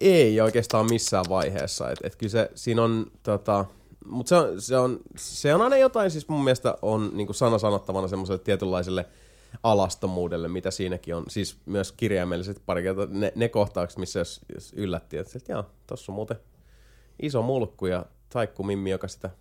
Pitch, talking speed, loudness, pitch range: 100 Hz, 175 wpm, -26 LUFS, 95-115 Hz